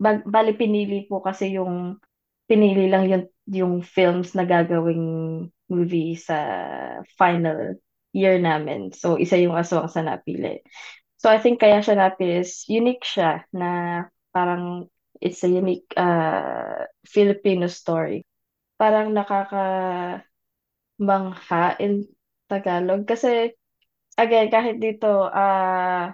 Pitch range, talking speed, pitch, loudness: 175-205 Hz, 115 wpm, 185 Hz, -22 LUFS